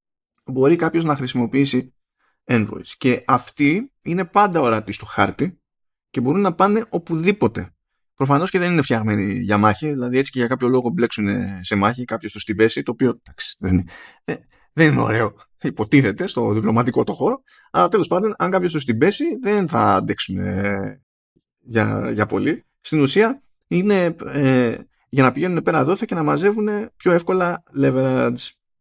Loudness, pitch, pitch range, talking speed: -19 LUFS, 135 Hz, 110-180 Hz, 165 wpm